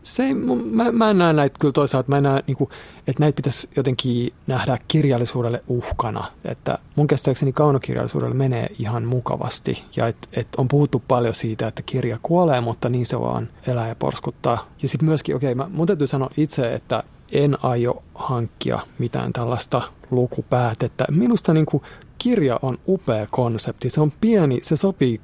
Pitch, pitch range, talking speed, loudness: 135 Hz, 125-150 Hz, 175 wpm, -21 LUFS